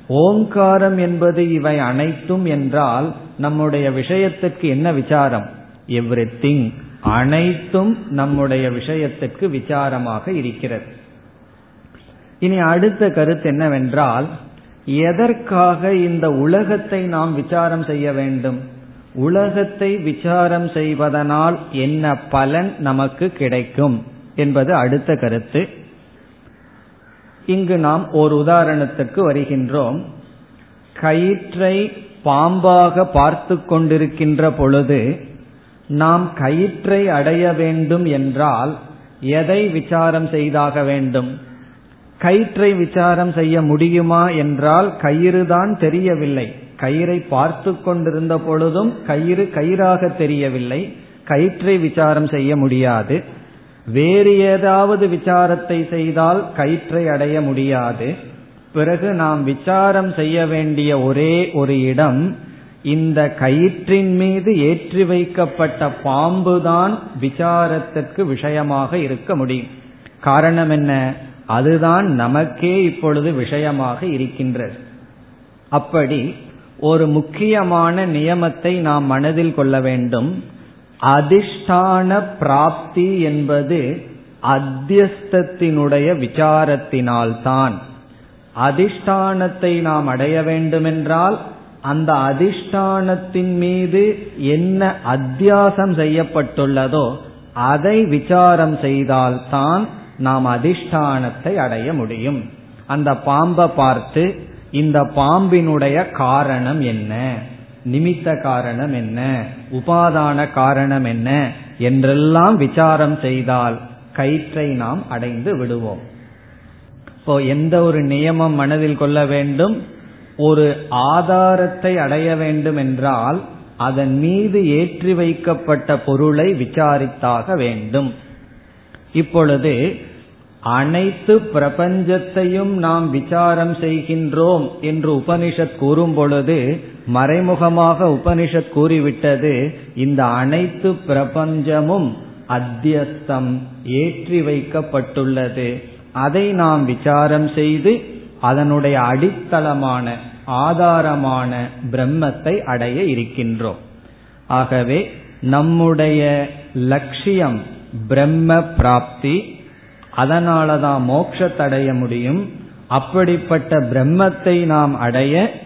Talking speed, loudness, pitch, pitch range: 75 wpm, -16 LUFS, 150 Hz, 135-175 Hz